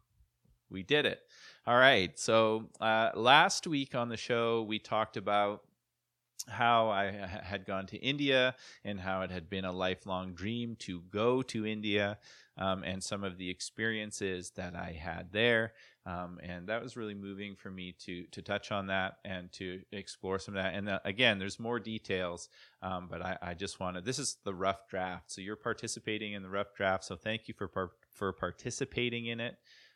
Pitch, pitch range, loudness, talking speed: 100 Hz, 95-115 Hz, -33 LUFS, 190 wpm